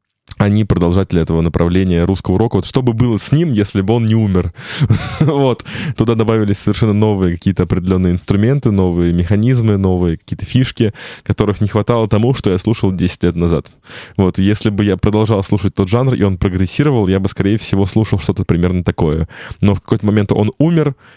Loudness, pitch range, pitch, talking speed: -14 LUFS, 95-110 Hz, 105 Hz, 185 wpm